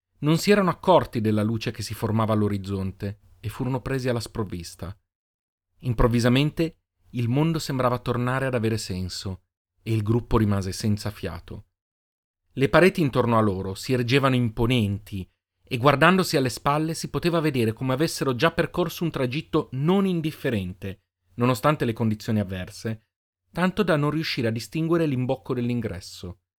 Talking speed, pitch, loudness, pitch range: 145 wpm, 120 Hz, -24 LUFS, 100-145 Hz